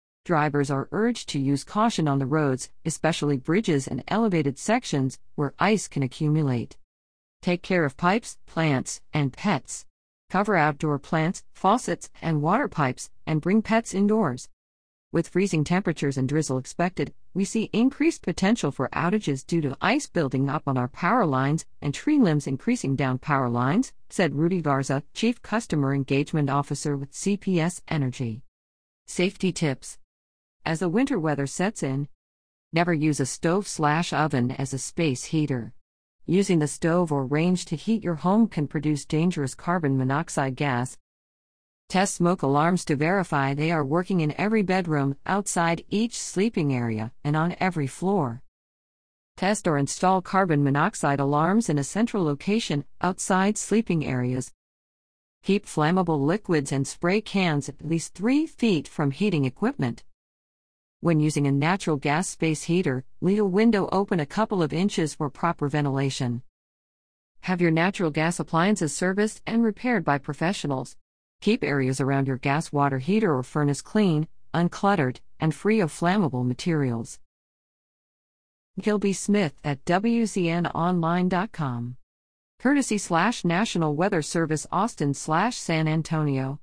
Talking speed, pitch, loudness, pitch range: 140 wpm, 155 Hz, -25 LUFS, 135-185 Hz